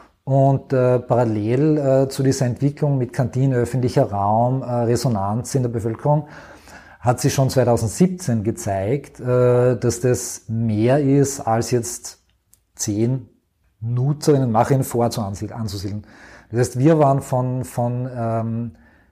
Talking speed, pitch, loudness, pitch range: 125 wpm, 125 Hz, -20 LUFS, 115-135 Hz